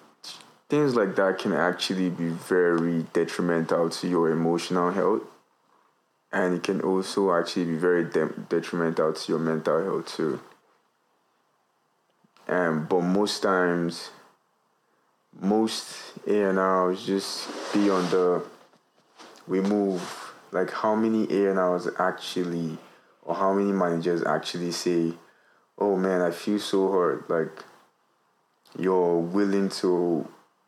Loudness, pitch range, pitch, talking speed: -26 LUFS, 85-95 Hz, 90 Hz, 120 wpm